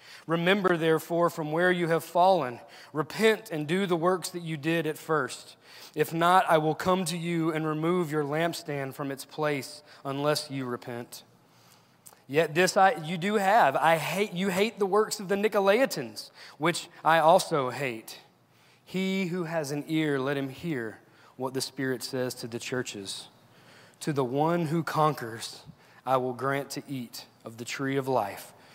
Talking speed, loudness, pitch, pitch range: 175 wpm, -28 LUFS, 155 Hz, 135-175 Hz